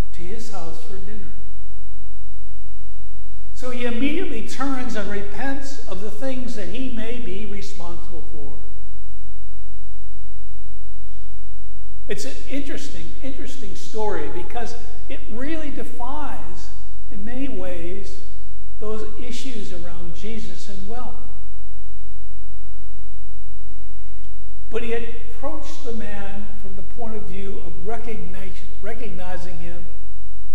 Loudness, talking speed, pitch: -34 LUFS, 100 wpm, 115 Hz